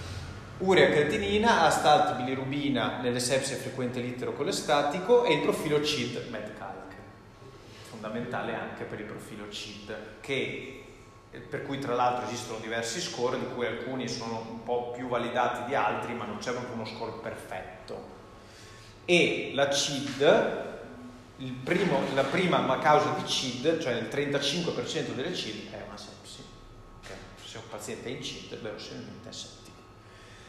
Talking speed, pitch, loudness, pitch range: 145 wpm, 120 Hz, -29 LUFS, 110-140 Hz